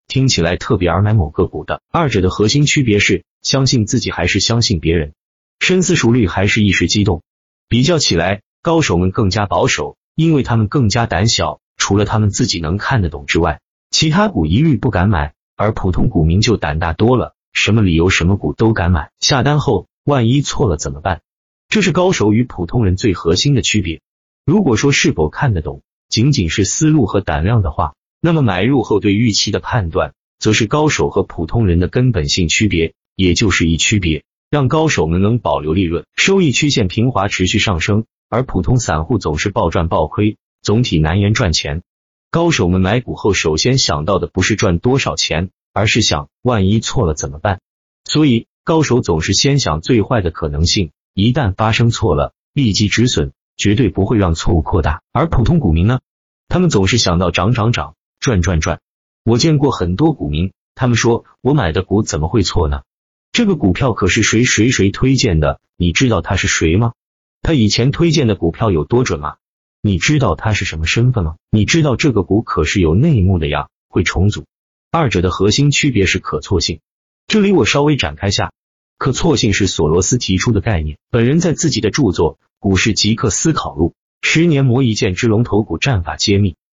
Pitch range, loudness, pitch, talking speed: 90-125 Hz, -15 LUFS, 105 Hz, 290 characters per minute